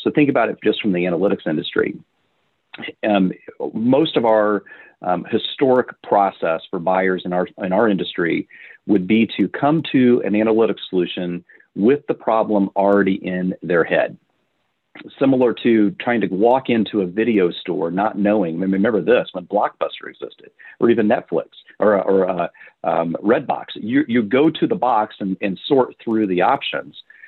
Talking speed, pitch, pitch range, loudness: 165 wpm, 110 Hz, 95-135 Hz, -19 LUFS